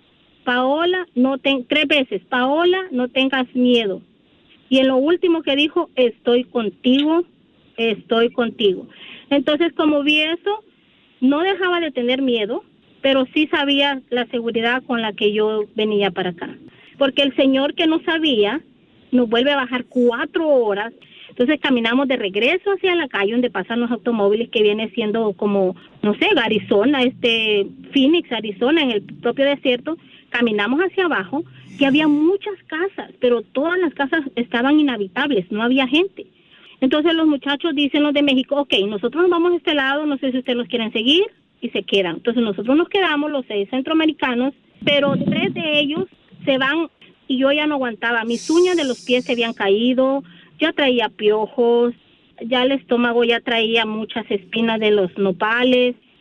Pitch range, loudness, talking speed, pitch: 230-295 Hz, -18 LUFS, 165 wpm, 260 Hz